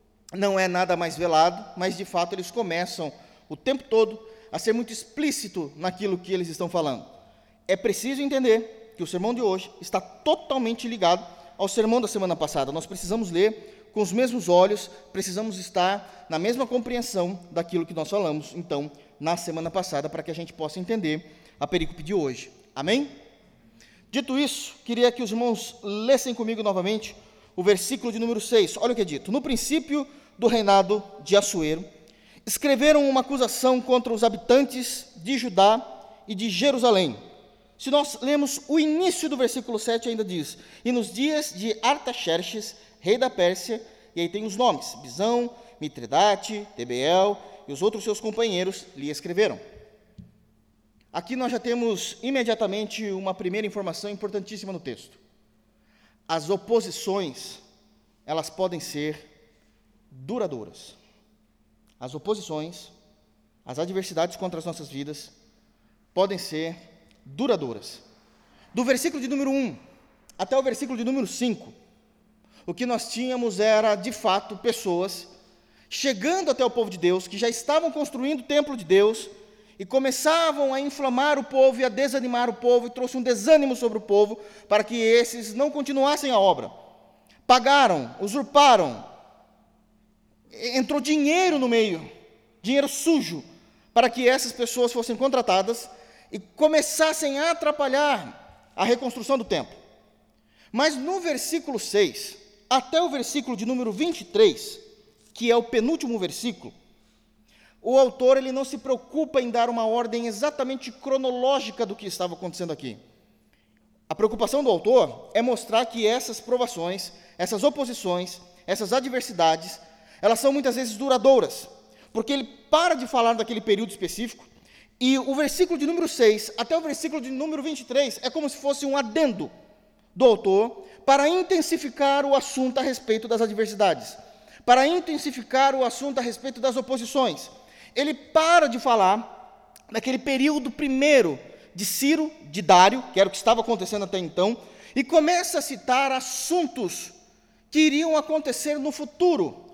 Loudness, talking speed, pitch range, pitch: -24 LUFS, 150 wpm, 195-270 Hz, 230 Hz